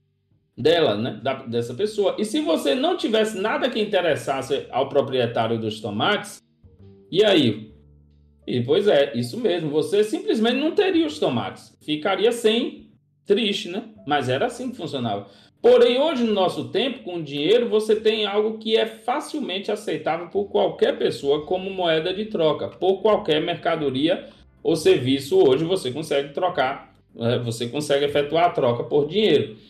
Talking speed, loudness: 155 wpm, -22 LUFS